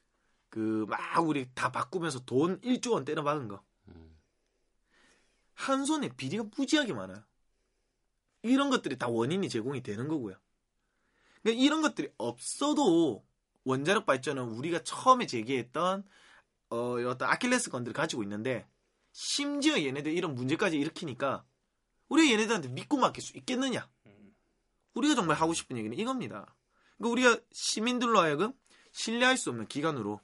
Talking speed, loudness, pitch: 325 characters per minute, -30 LUFS, 175 Hz